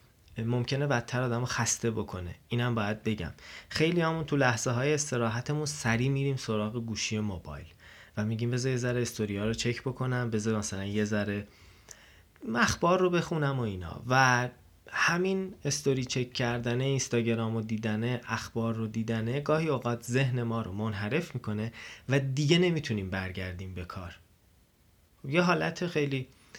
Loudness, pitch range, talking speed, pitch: -30 LUFS, 105-135 Hz, 145 wpm, 120 Hz